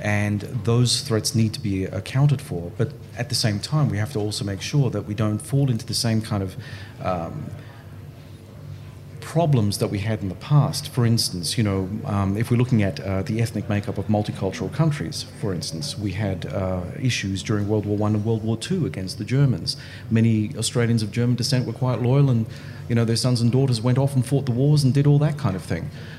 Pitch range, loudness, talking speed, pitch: 105-130 Hz, -23 LUFS, 220 wpm, 115 Hz